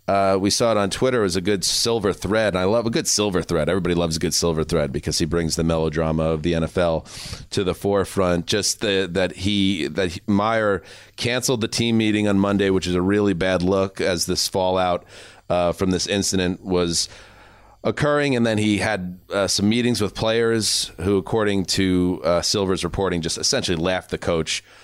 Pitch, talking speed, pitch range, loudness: 95 Hz, 200 wpm, 90-105 Hz, -21 LUFS